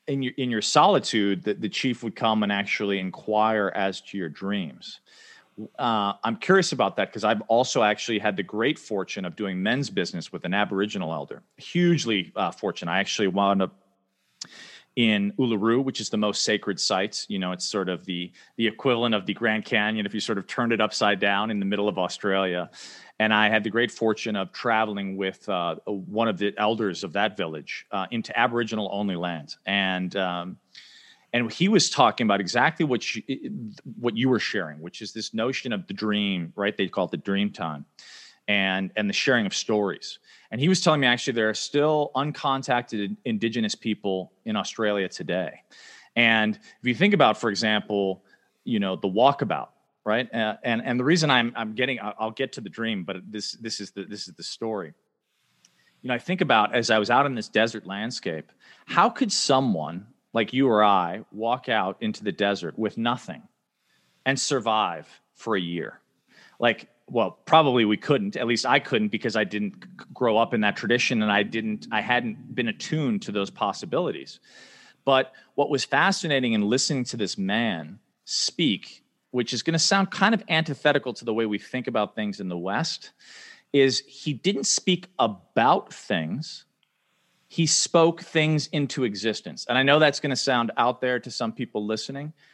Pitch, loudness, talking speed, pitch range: 110 Hz, -25 LUFS, 190 wpm, 100-130 Hz